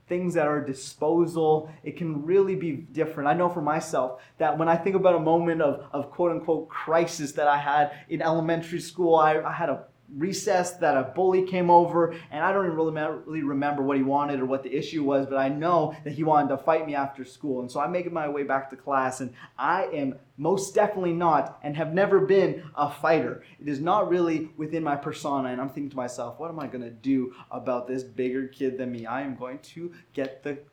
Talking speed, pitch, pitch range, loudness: 230 wpm, 155 Hz, 135-165 Hz, -26 LUFS